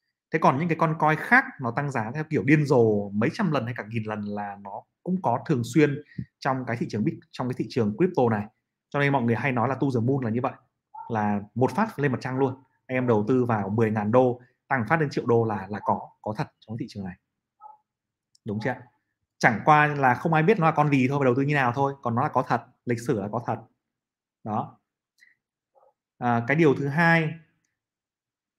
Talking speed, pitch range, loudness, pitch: 240 wpm, 115-150 Hz, -25 LUFS, 130 Hz